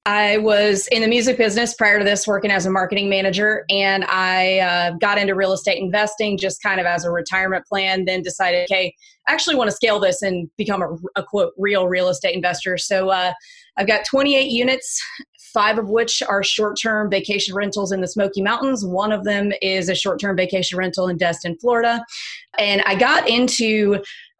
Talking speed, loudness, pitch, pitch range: 195 wpm, -18 LUFS, 200 Hz, 185-215 Hz